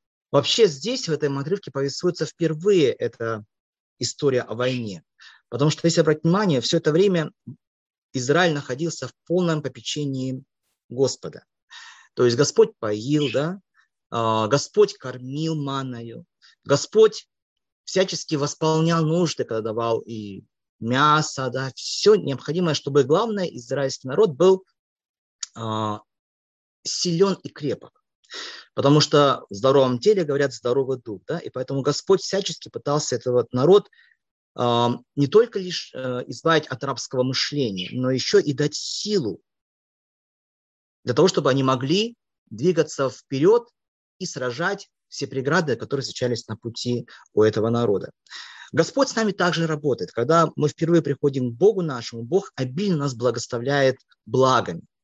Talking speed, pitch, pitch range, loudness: 130 wpm, 145 Hz, 125-170 Hz, -22 LUFS